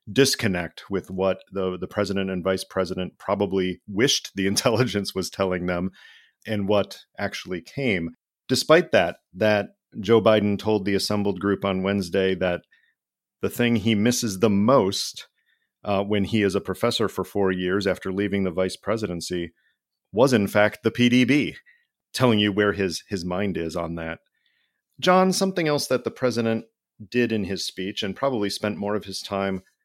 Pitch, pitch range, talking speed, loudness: 100 Hz, 95-115 Hz, 165 wpm, -23 LUFS